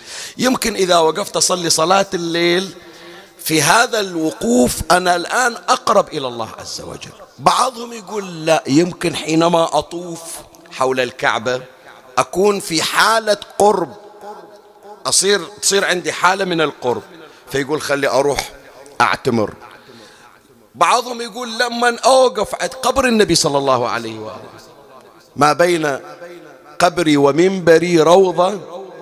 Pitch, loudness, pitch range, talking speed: 175 Hz, -15 LUFS, 155-205 Hz, 110 wpm